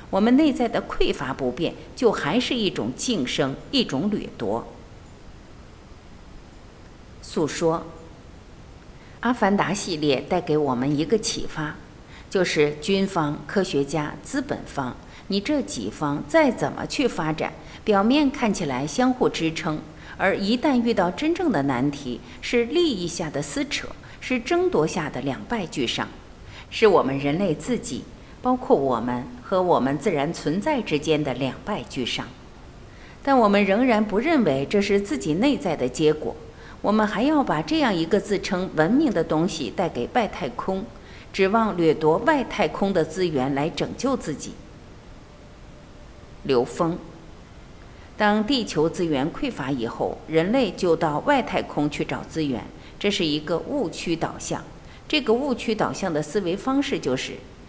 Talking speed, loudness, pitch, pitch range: 220 characters per minute, -23 LUFS, 180 Hz, 145-240 Hz